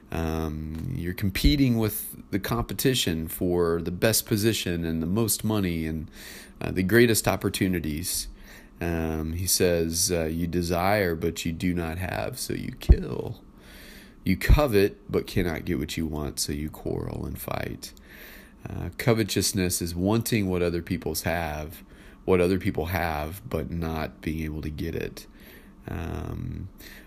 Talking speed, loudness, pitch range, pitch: 145 wpm, -27 LUFS, 80-100 Hz, 85 Hz